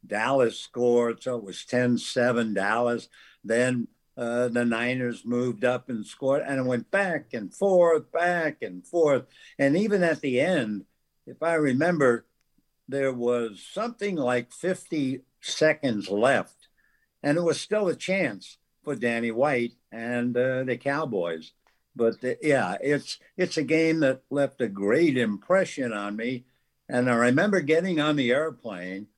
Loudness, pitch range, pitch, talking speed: -26 LUFS, 120-155 Hz, 125 Hz, 150 wpm